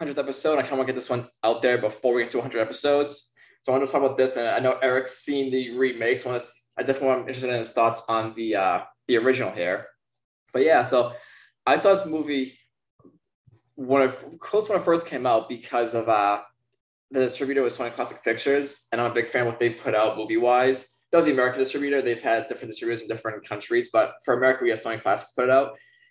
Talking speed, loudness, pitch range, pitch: 250 wpm, -24 LUFS, 115-135 Hz, 130 Hz